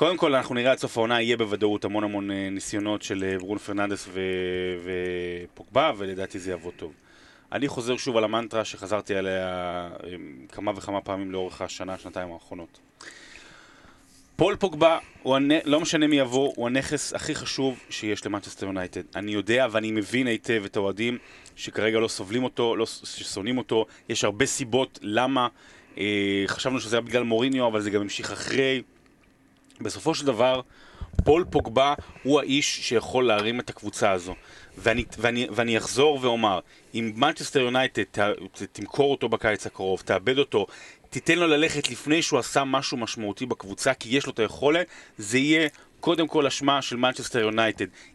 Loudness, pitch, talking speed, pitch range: -25 LUFS, 115 Hz, 155 wpm, 100-130 Hz